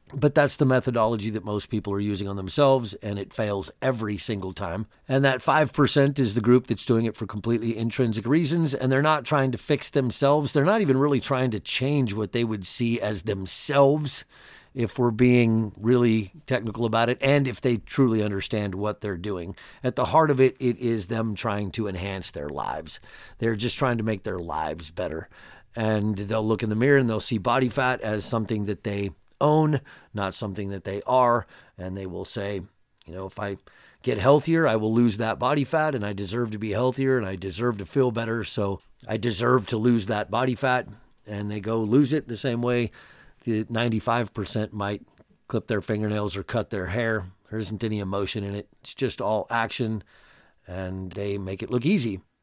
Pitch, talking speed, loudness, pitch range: 115 Hz, 205 wpm, -25 LUFS, 105-130 Hz